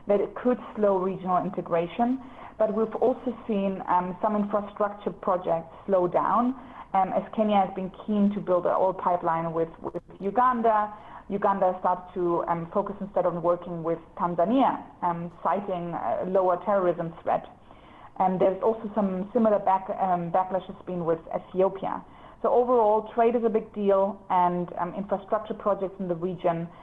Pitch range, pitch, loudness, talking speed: 180-210 Hz, 190 Hz, -26 LUFS, 160 wpm